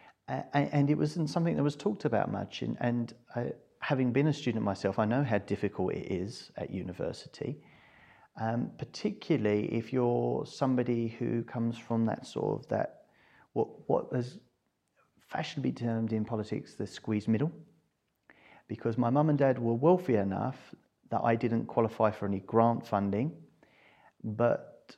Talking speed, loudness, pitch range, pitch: 155 wpm, -32 LUFS, 110-145 Hz, 120 Hz